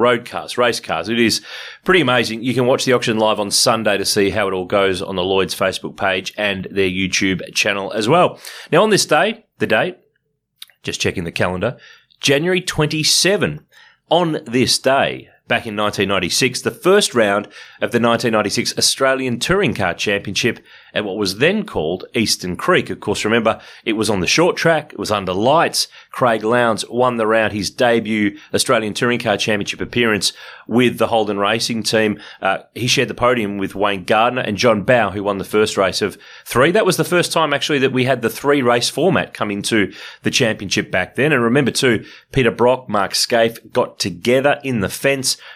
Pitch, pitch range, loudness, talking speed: 115 Hz, 100-125 Hz, -17 LUFS, 195 wpm